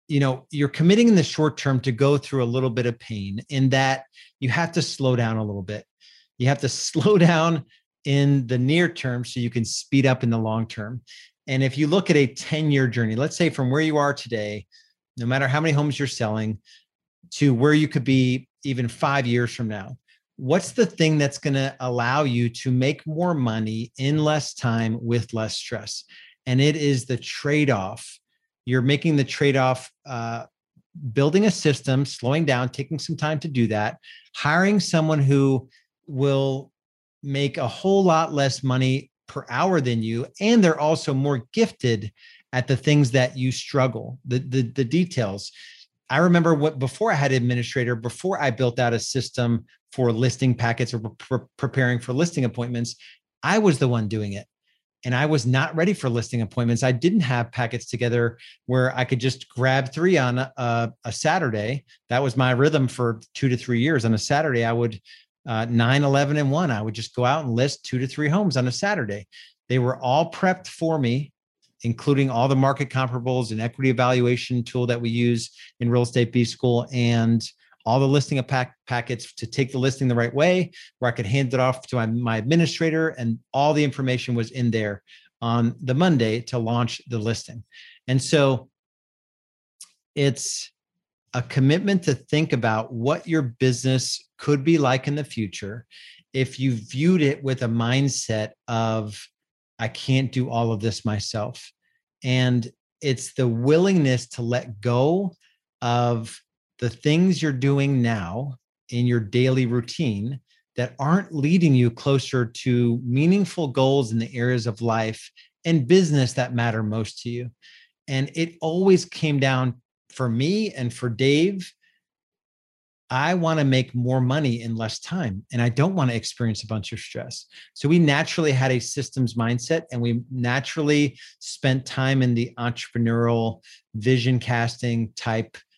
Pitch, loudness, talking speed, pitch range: 130 Hz, -23 LUFS, 180 wpm, 120-145 Hz